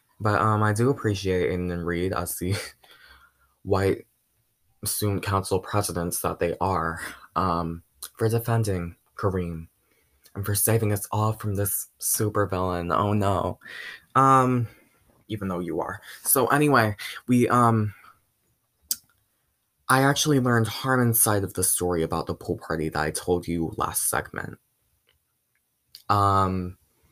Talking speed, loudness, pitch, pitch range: 130 wpm, -24 LUFS, 100 Hz, 90-115 Hz